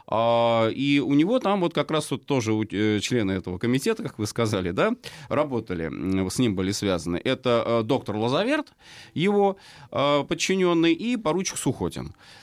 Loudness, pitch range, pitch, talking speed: -24 LUFS, 105-155 Hz, 125 Hz, 140 wpm